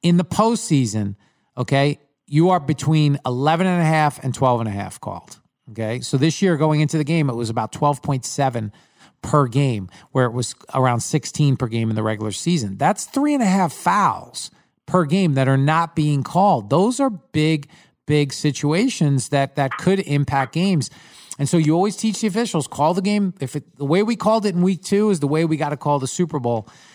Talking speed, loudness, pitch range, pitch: 220 wpm, -20 LUFS, 135-180 Hz, 150 Hz